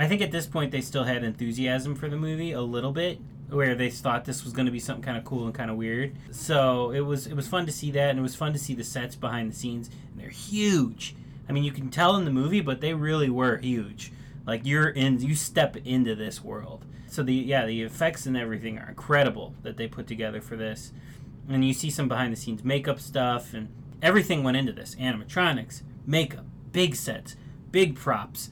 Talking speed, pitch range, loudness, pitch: 230 wpm, 120-145 Hz, -27 LUFS, 135 Hz